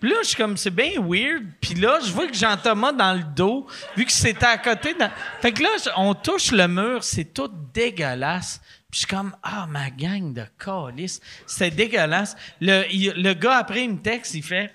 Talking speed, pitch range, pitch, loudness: 225 wpm, 185-240 Hz, 200 Hz, -21 LUFS